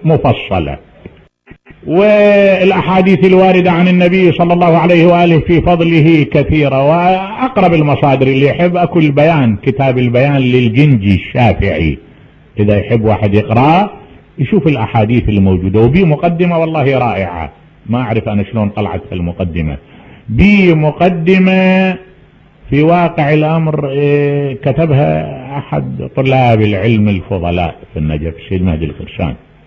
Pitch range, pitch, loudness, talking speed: 105-170 Hz, 140 Hz, -11 LUFS, 110 wpm